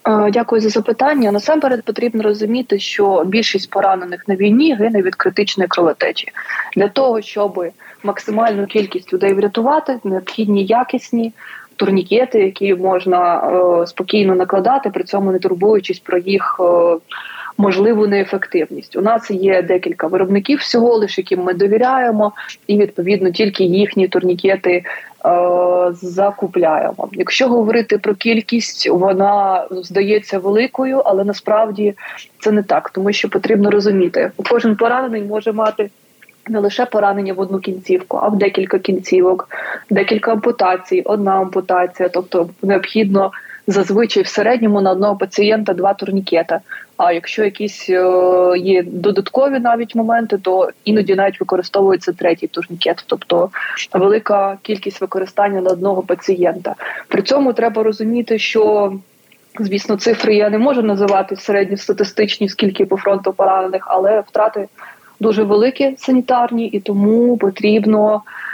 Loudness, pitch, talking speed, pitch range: -15 LUFS, 200 Hz, 130 wpm, 190-220 Hz